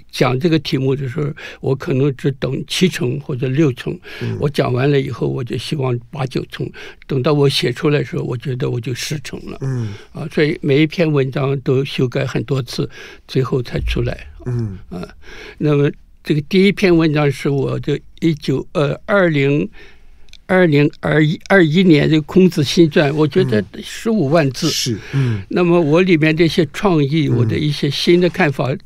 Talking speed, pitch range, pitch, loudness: 260 characters per minute, 135-165 Hz, 150 Hz, -17 LUFS